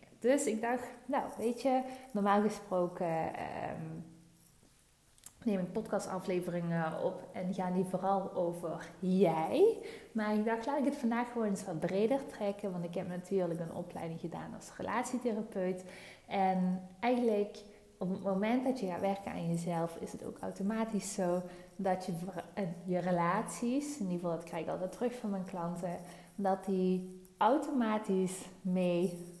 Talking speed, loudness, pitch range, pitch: 155 wpm, -35 LUFS, 180-220 Hz, 190 Hz